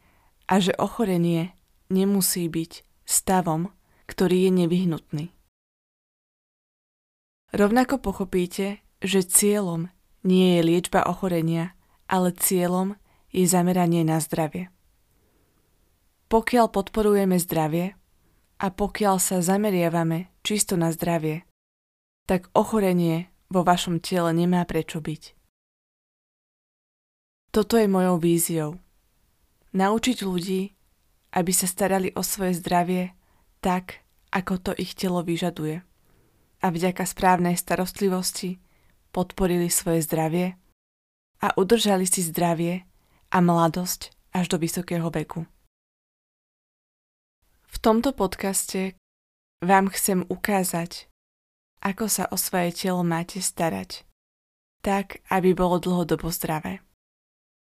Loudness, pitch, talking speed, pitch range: -24 LUFS, 180 Hz, 100 wpm, 165-190 Hz